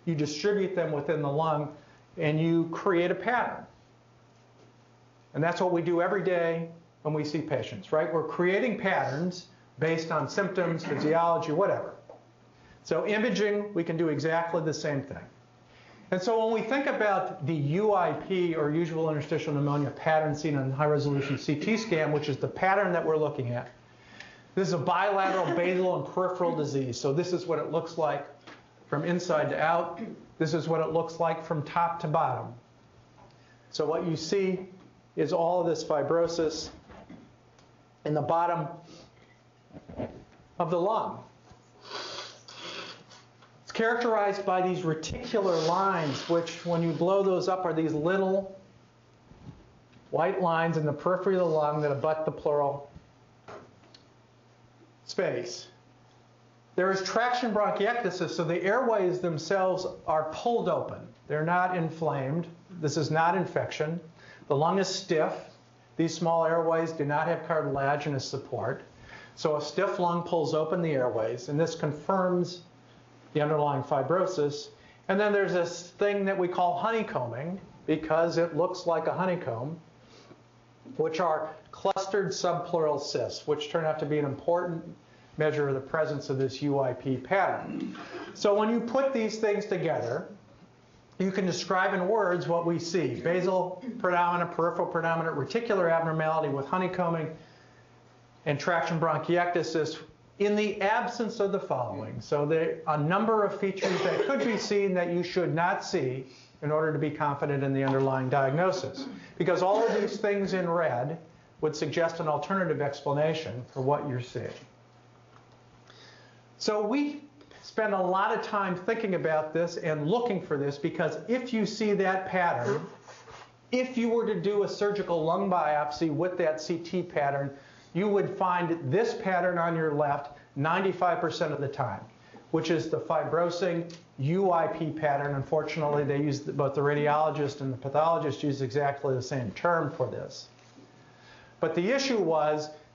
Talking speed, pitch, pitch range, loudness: 155 wpm, 165 Hz, 145-180 Hz, -29 LUFS